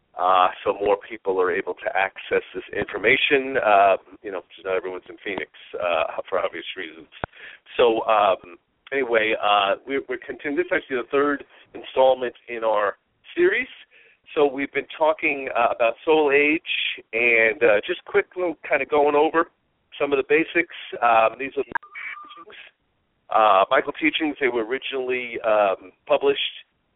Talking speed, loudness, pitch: 155 wpm, -22 LUFS, 165 Hz